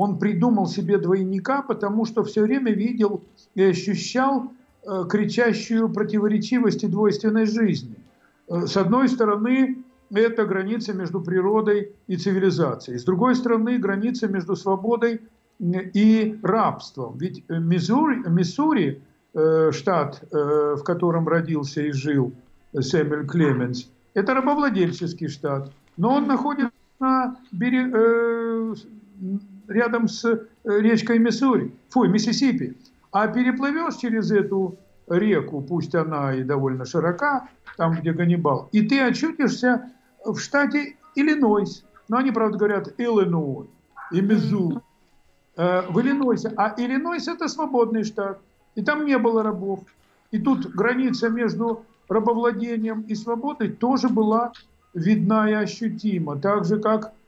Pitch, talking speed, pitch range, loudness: 215 Hz, 125 wpm, 185-235 Hz, -22 LUFS